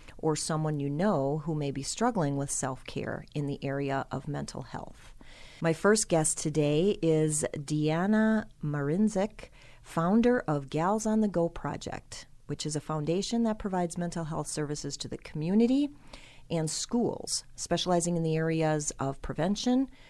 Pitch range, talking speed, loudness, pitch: 140-185 Hz, 150 wpm, -30 LUFS, 155 Hz